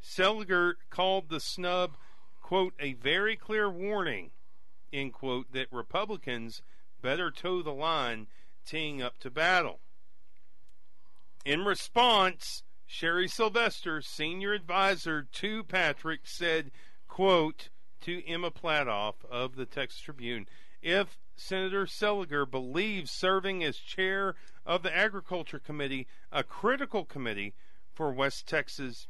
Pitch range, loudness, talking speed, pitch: 140-190 Hz, -31 LUFS, 115 wpm, 170 Hz